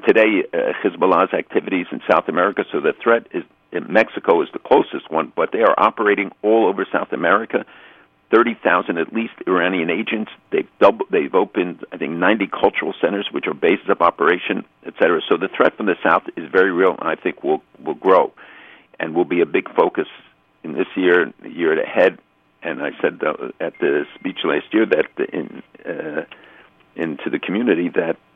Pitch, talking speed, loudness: 375 Hz, 190 wpm, -19 LUFS